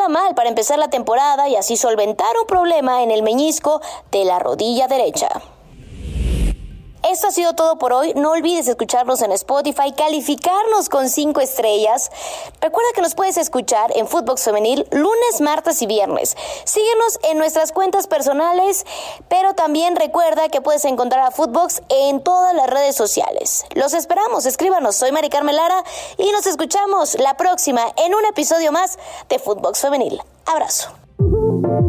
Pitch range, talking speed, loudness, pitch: 260-355 Hz, 150 wpm, -17 LUFS, 310 Hz